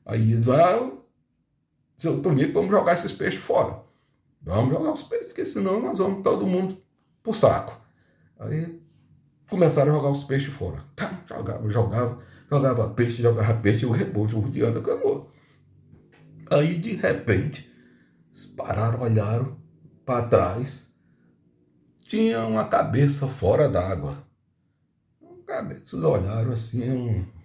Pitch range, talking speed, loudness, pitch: 105-150 Hz, 130 wpm, -24 LUFS, 120 Hz